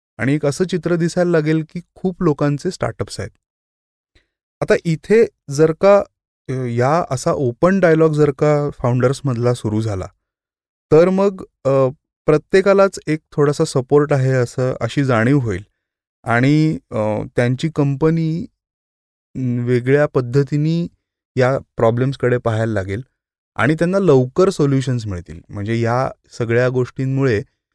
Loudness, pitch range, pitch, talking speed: -17 LUFS, 120-160 Hz, 135 Hz, 115 wpm